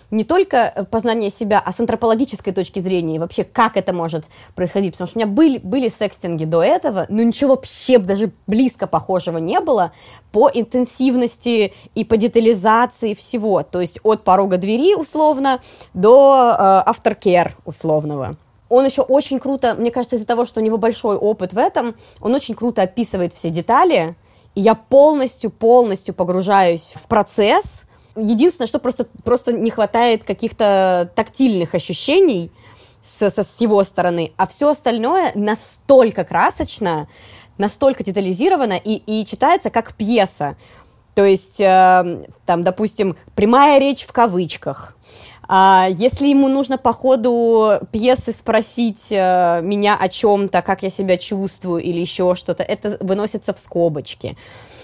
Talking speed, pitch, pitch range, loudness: 145 wpm, 210 Hz, 185-240 Hz, -16 LUFS